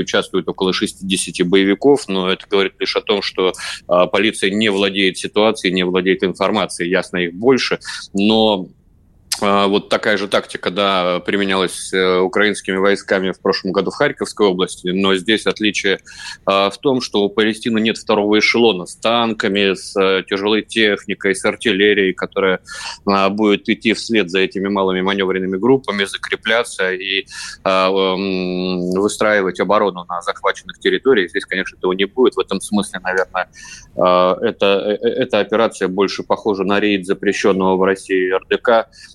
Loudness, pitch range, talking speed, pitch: -16 LUFS, 95-105 Hz, 140 wpm, 100 Hz